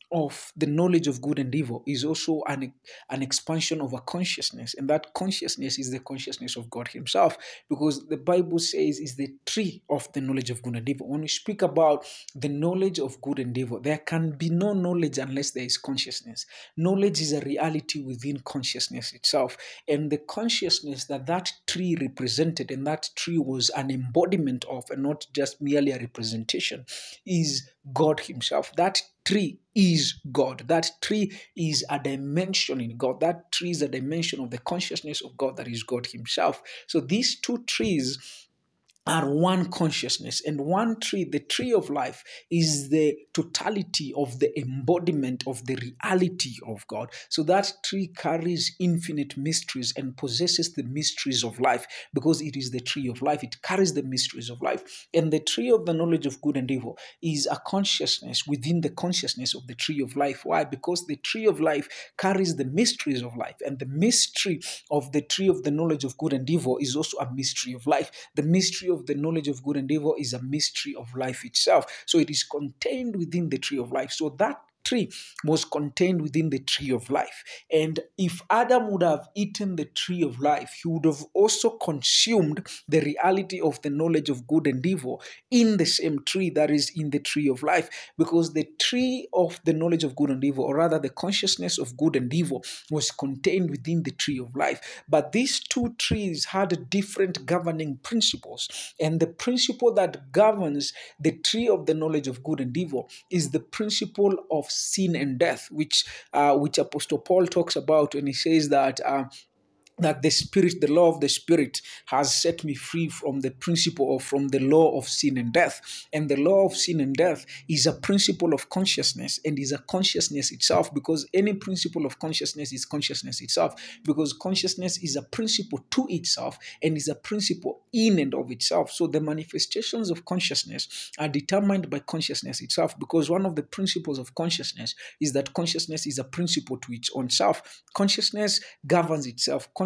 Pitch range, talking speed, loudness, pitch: 140-175 Hz, 190 wpm, -26 LUFS, 155 Hz